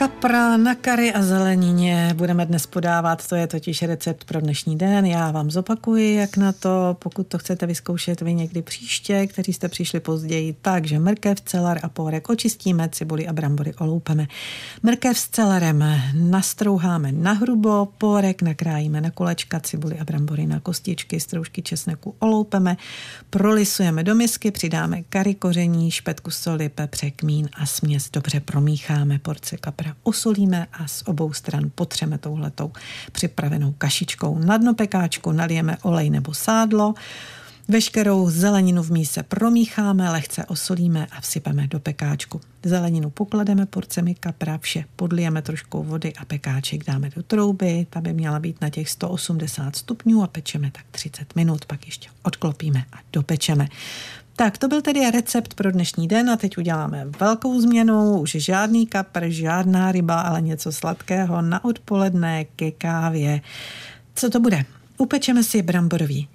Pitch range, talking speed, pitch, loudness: 155-195 Hz, 150 wpm, 170 Hz, -21 LUFS